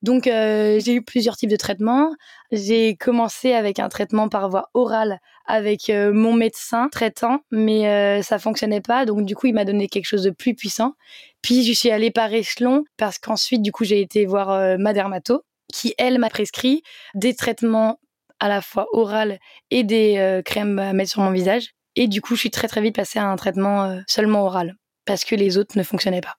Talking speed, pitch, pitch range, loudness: 215 wpm, 215 Hz, 200-235 Hz, -20 LUFS